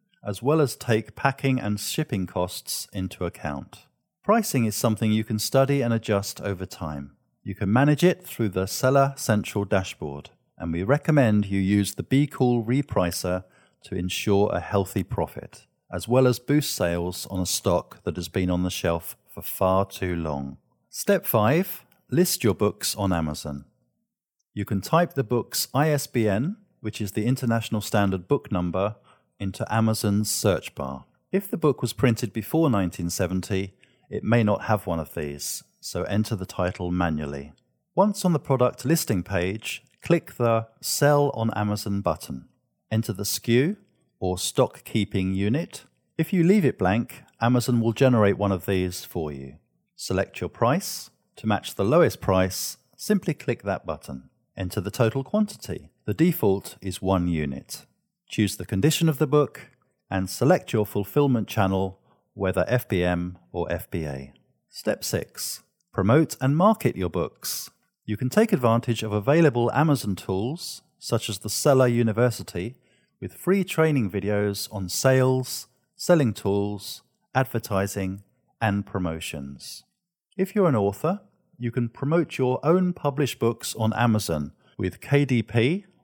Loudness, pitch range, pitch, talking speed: -25 LUFS, 95-135 Hz, 110 Hz, 150 wpm